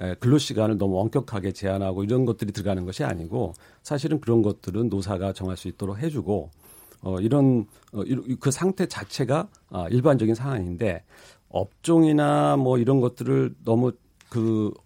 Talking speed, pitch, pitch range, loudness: 315 characters per minute, 110 Hz, 95-130 Hz, -24 LUFS